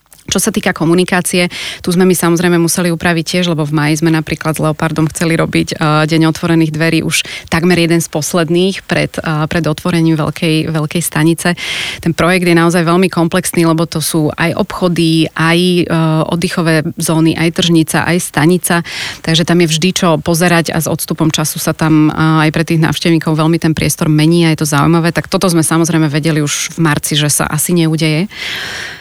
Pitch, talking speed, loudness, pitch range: 165 Hz, 180 wpm, -12 LUFS, 160-175 Hz